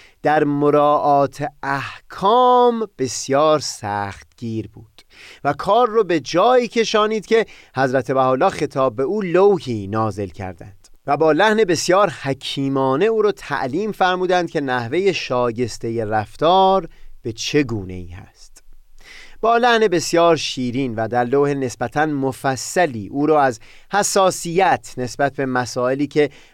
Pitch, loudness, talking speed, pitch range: 140 Hz, -18 LUFS, 130 wpm, 125-180 Hz